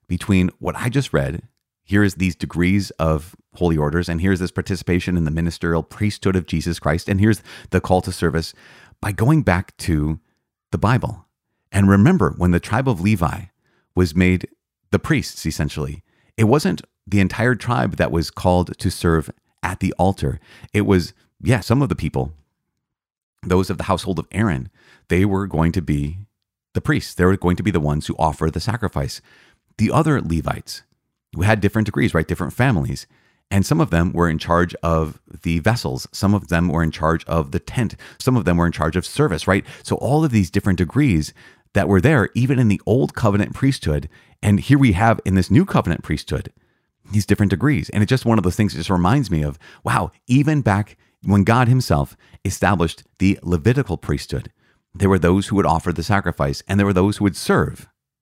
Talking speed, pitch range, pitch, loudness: 200 wpm, 85-105 Hz, 95 Hz, -19 LUFS